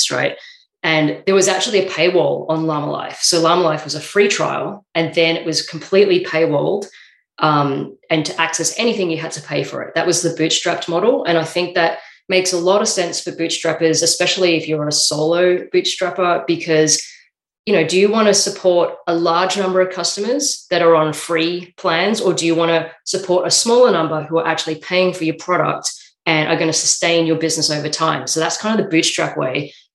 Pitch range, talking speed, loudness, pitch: 160-185 Hz, 210 wpm, -16 LUFS, 170 Hz